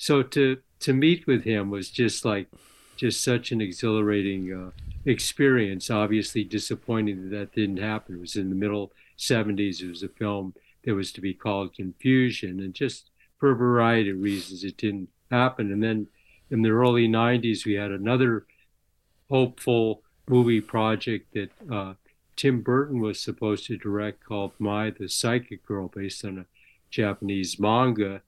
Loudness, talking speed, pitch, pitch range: -26 LUFS, 165 wpm, 105 Hz, 100-115 Hz